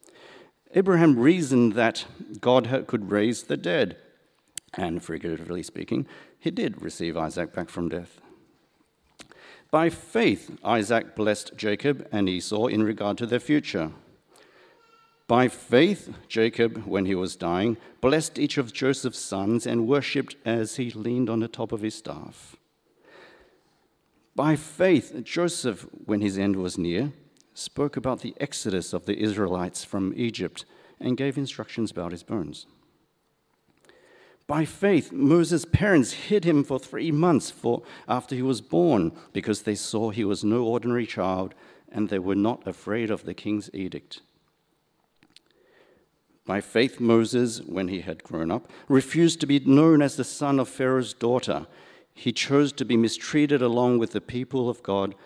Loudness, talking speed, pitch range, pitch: -25 LUFS, 150 wpm, 100-140 Hz, 120 Hz